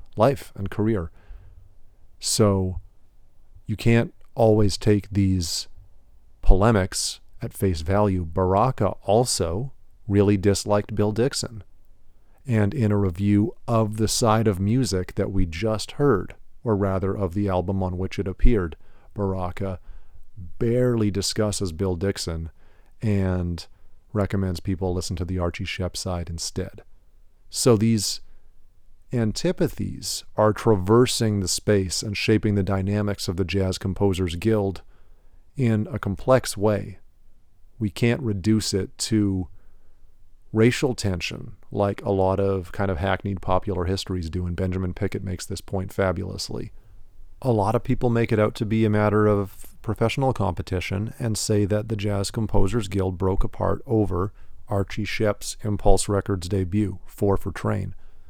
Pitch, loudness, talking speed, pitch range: 100 Hz, -24 LUFS, 135 wpm, 95-110 Hz